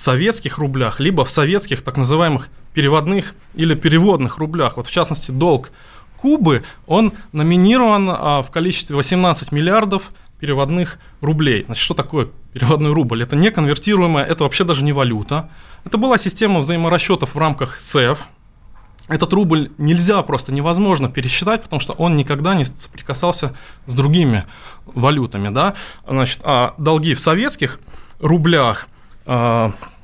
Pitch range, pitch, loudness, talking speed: 135-175 Hz, 155 Hz, -16 LUFS, 135 wpm